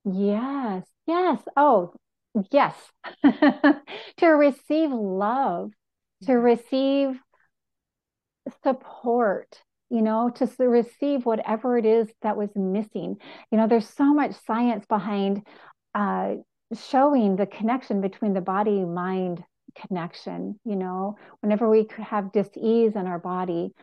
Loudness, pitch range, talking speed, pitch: -24 LUFS, 205-265 Hz, 115 wpm, 225 Hz